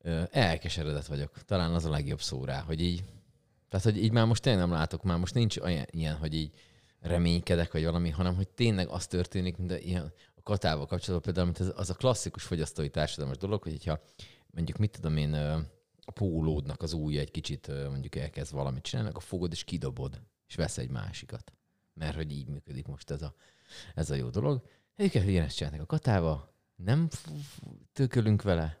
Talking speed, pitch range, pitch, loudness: 190 wpm, 80-100 Hz, 85 Hz, -32 LUFS